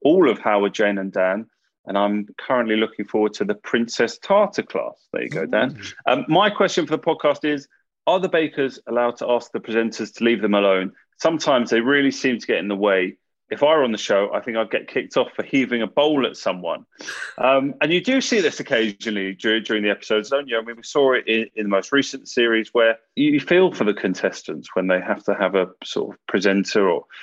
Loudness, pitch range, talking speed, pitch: -21 LUFS, 105-140 Hz, 235 wpm, 115 Hz